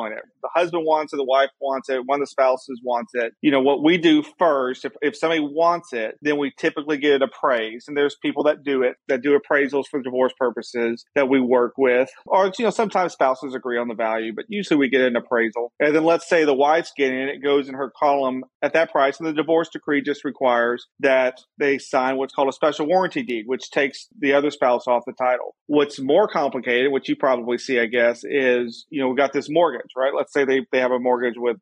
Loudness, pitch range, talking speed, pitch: -21 LUFS, 125-150 Hz, 240 wpm, 135 Hz